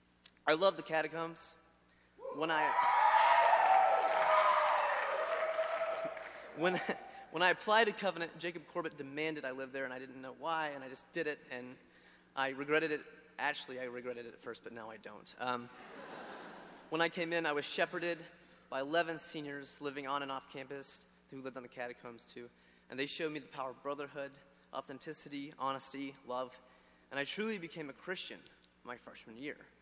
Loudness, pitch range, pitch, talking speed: -36 LUFS, 130-170 Hz, 145 Hz, 170 wpm